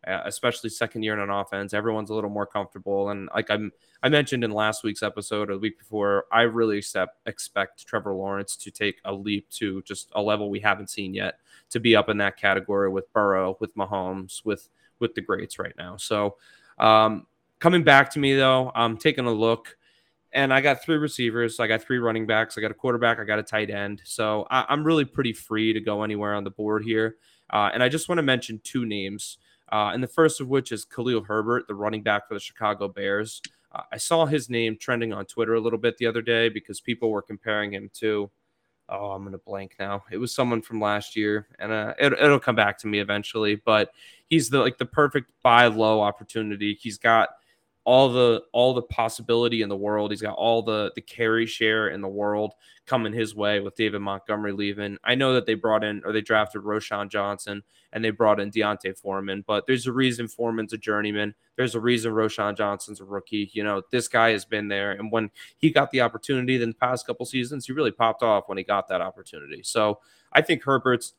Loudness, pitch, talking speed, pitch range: -24 LUFS, 110 Hz, 225 wpm, 105-120 Hz